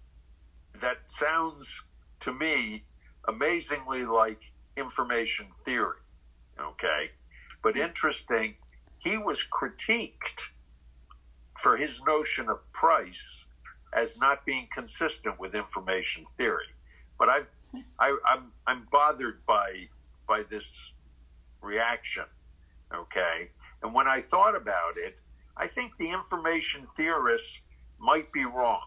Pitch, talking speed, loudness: 75 Hz, 105 wpm, -29 LUFS